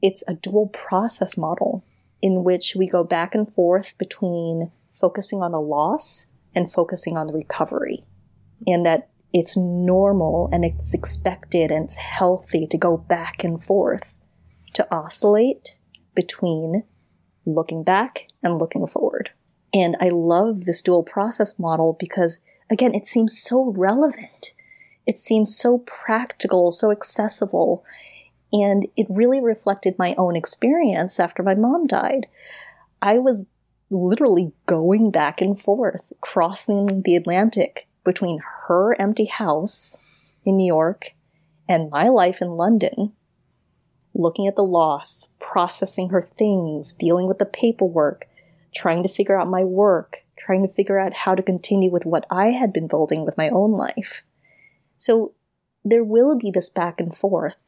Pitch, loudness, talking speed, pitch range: 185 Hz, -20 LUFS, 145 wpm, 170-210 Hz